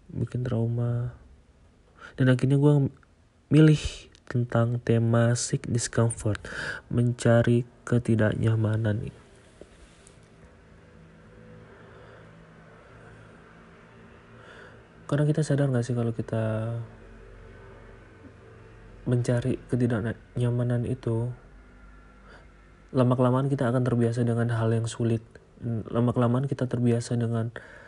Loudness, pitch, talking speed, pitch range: -26 LUFS, 115 Hz, 75 wpm, 110-125 Hz